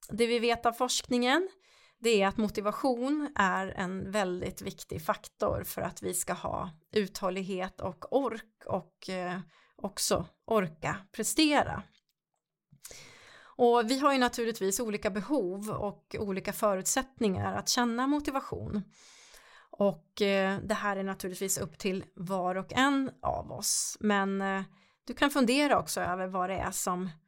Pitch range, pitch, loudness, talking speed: 190-250 Hz, 210 Hz, -31 LUFS, 140 wpm